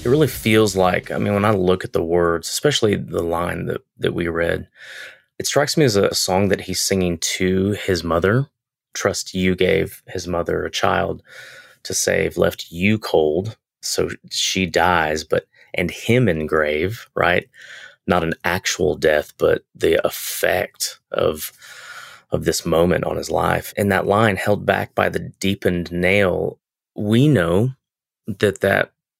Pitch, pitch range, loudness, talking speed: 95 Hz, 85-105 Hz, -19 LUFS, 160 wpm